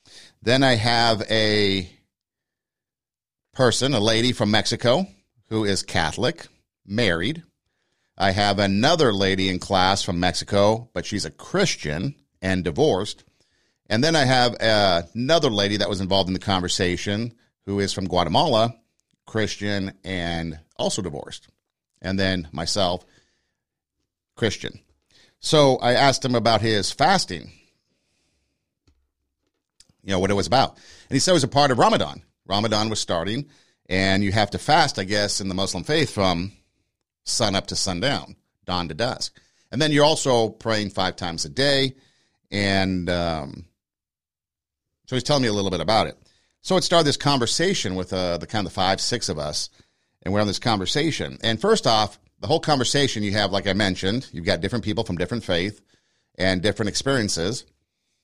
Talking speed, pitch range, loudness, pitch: 160 wpm, 95-120 Hz, -22 LUFS, 100 Hz